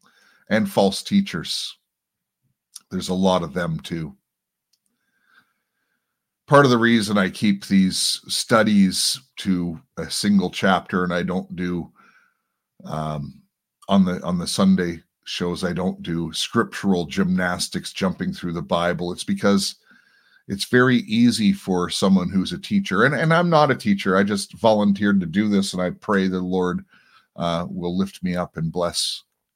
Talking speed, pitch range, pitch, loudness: 150 wpm, 90-105 Hz, 95 Hz, -21 LUFS